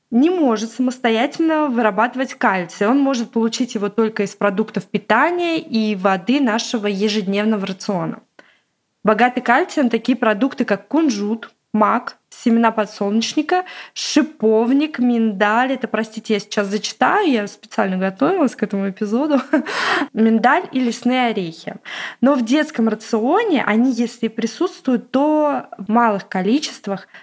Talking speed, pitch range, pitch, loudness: 120 wpm, 215-270 Hz, 230 Hz, -18 LUFS